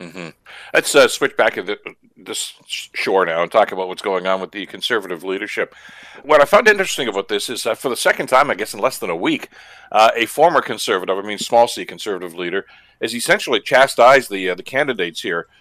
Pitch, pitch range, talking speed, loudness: 95 Hz, 95-120 Hz, 225 wpm, -17 LUFS